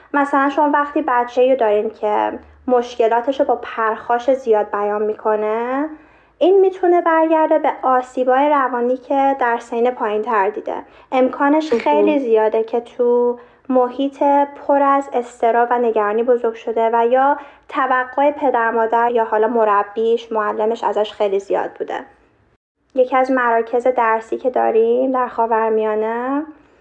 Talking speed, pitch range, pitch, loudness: 135 wpm, 225-275 Hz, 245 Hz, -17 LUFS